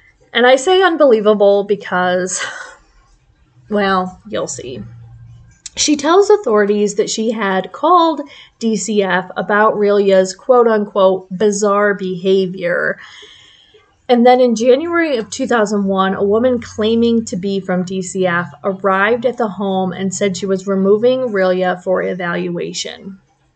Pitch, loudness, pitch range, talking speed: 205 Hz, -15 LUFS, 190-235 Hz, 120 wpm